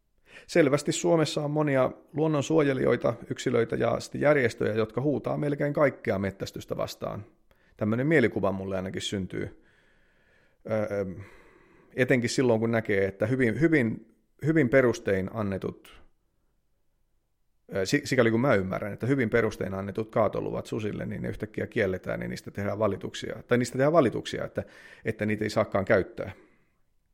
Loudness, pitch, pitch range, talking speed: -27 LUFS, 115 Hz, 100-140 Hz, 125 wpm